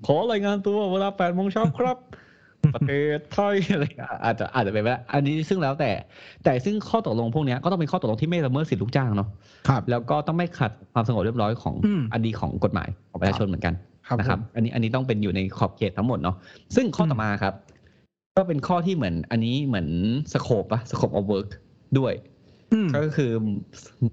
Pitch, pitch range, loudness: 125 Hz, 105-160 Hz, -25 LUFS